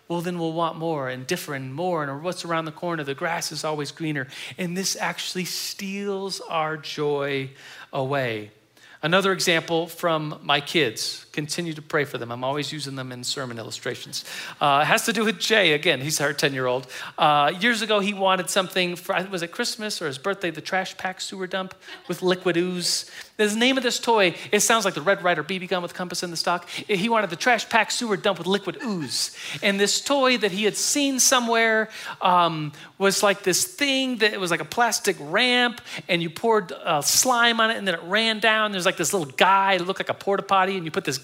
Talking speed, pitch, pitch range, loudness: 220 wpm, 185 Hz, 160-205 Hz, -23 LUFS